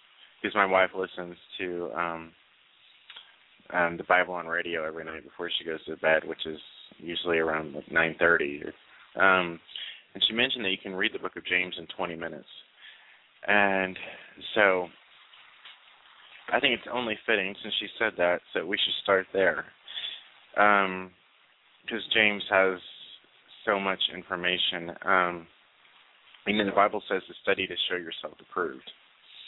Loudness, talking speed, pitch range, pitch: -27 LUFS, 155 wpm, 85-95 Hz, 90 Hz